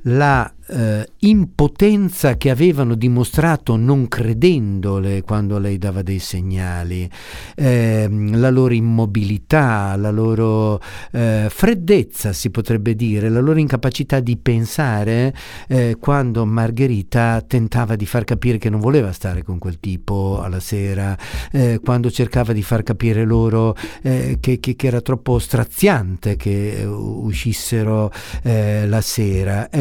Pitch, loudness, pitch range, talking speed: 115 Hz, -18 LUFS, 105-125 Hz, 130 wpm